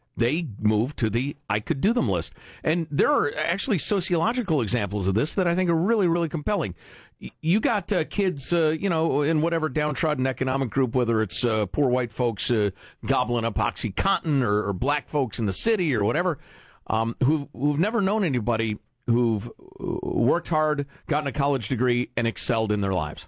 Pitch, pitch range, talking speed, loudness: 135 Hz, 115-160 Hz, 190 wpm, -24 LUFS